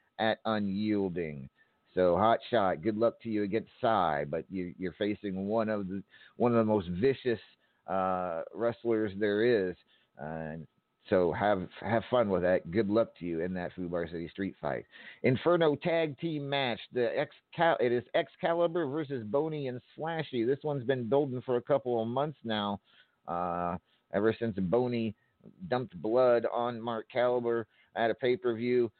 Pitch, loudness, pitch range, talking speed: 115 Hz, -31 LUFS, 95-125 Hz, 175 wpm